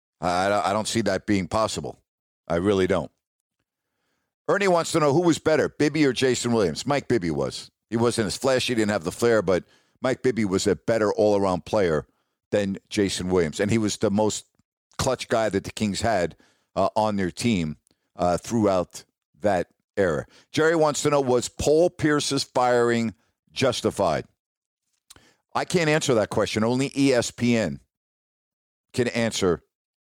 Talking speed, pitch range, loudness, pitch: 160 wpm, 100-135 Hz, -24 LUFS, 115 Hz